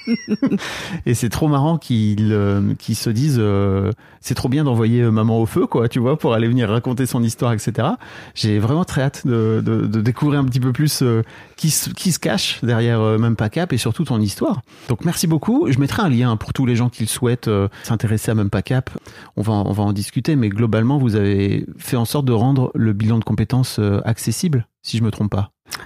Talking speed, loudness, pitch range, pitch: 230 wpm, -19 LUFS, 110-135 Hz, 120 Hz